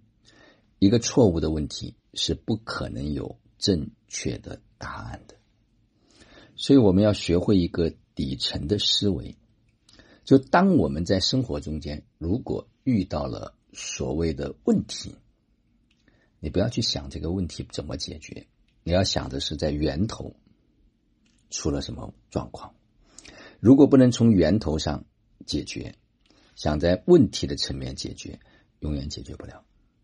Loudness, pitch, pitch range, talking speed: -24 LUFS, 90 Hz, 75-105 Hz, 205 characters per minute